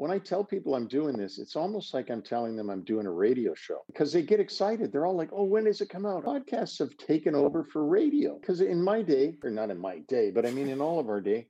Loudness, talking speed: -29 LUFS, 280 wpm